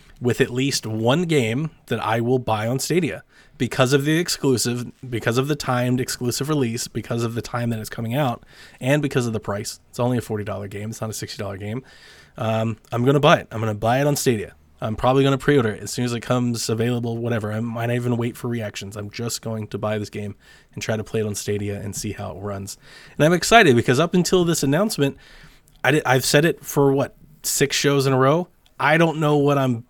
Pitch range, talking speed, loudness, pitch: 110-140 Hz, 245 wpm, -21 LUFS, 120 Hz